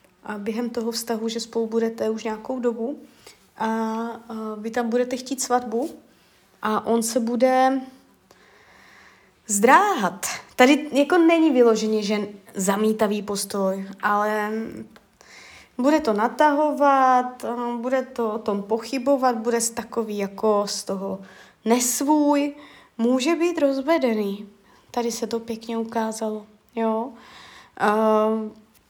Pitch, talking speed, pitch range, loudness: 230 Hz, 110 wpm, 215-255 Hz, -22 LUFS